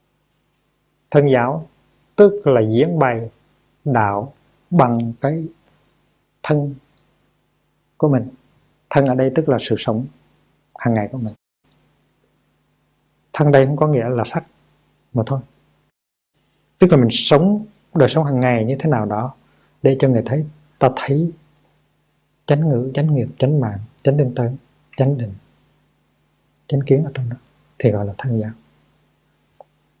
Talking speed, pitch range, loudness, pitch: 140 wpm, 120-150 Hz, -18 LUFS, 135 Hz